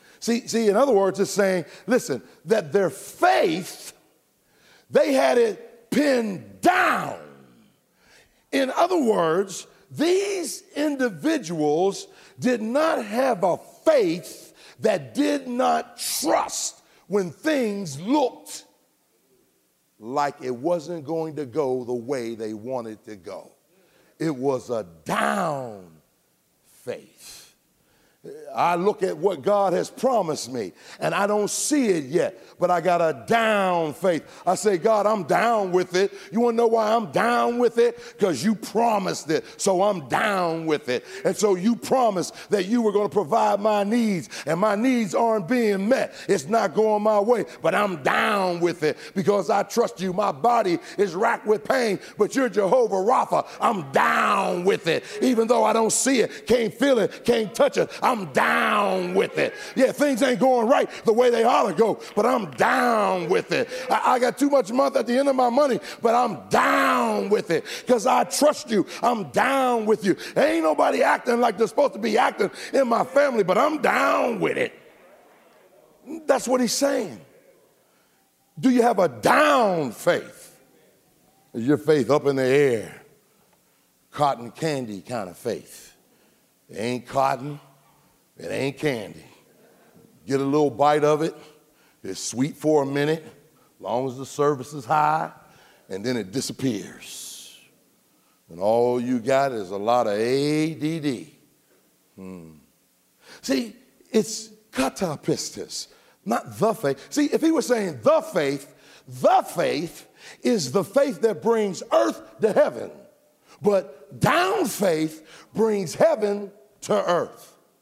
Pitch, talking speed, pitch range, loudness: 205 Hz, 155 wpm, 150-245 Hz, -22 LUFS